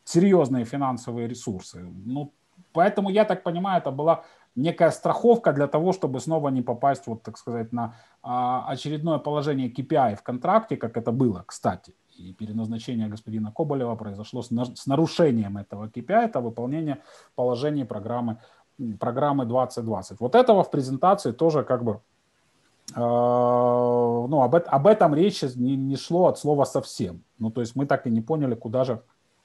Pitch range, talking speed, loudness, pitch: 120-150 Hz, 155 wpm, -24 LUFS, 130 Hz